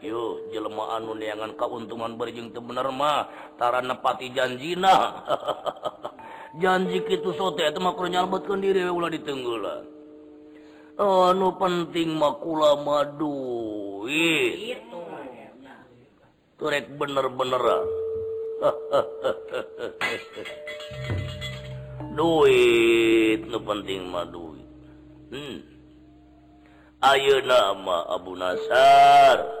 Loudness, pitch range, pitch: -23 LUFS, 115-190 Hz, 150 Hz